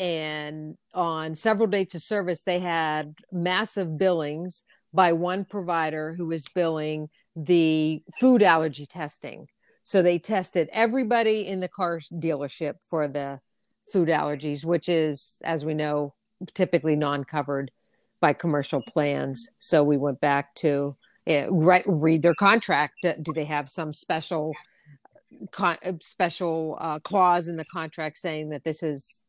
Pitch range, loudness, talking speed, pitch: 150-180 Hz, -25 LUFS, 135 wpm, 165 Hz